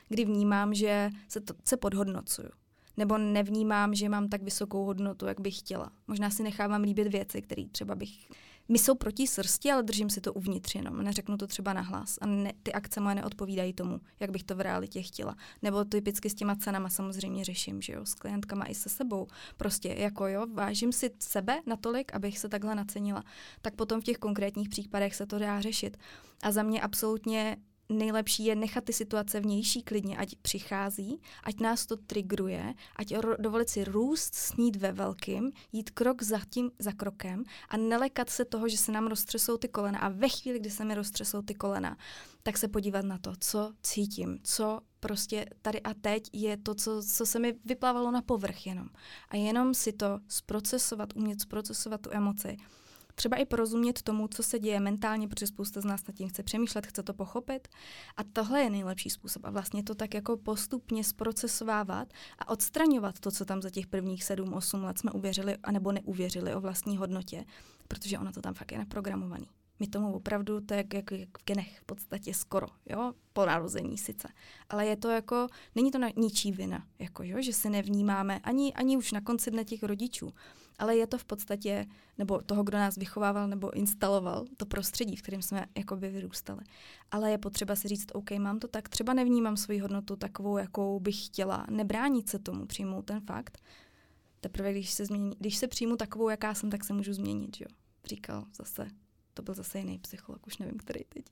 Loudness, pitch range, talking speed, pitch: -33 LUFS, 195-220 Hz, 195 wpm, 205 Hz